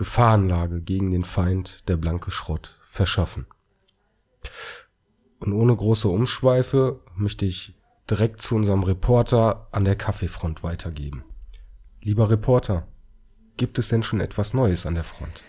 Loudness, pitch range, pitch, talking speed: -23 LUFS, 90-110 Hz, 100 Hz, 130 wpm